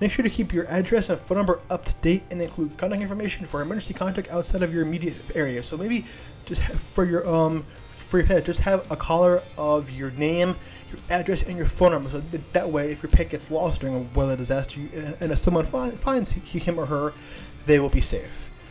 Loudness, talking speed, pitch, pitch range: -25 LUFS, 220 wpm, 170 Hz, 150-185 Hz